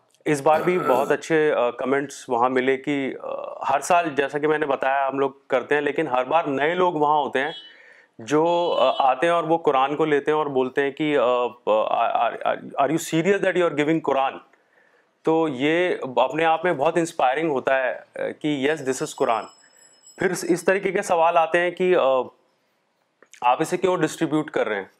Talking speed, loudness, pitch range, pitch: 185 wpm, -22 LUFS, 135-165 Hz, 155 Hz